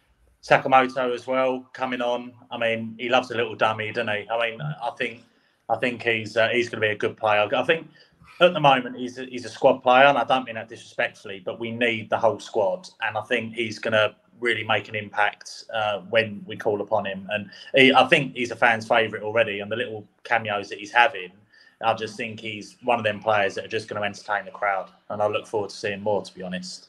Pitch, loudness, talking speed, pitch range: 115 Hz, -23 LUFS, 245 wpm, 110-125 Hz